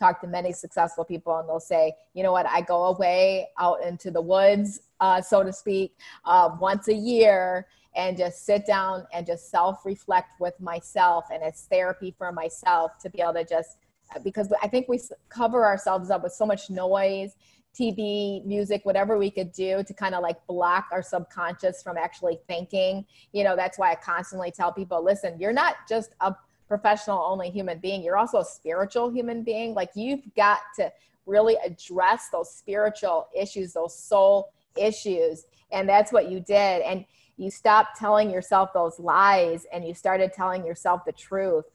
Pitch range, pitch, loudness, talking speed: 175-205 Hz, 190 Hz, -25 LUFS, 185 wpm